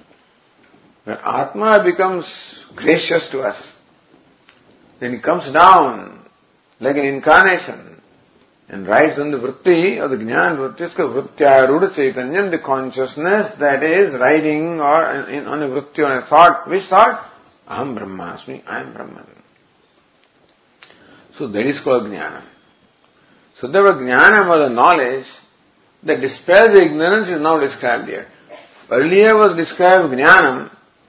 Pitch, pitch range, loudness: 155 Hz, 135-185 Hz, -14 LUFS